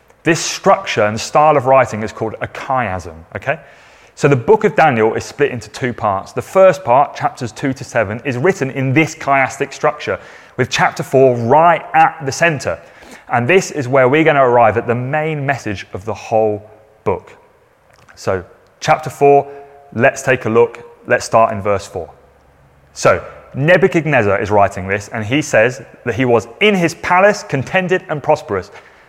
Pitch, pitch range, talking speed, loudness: 135 Hz, 115-155 Hz, 175 wpm, -15 LUFS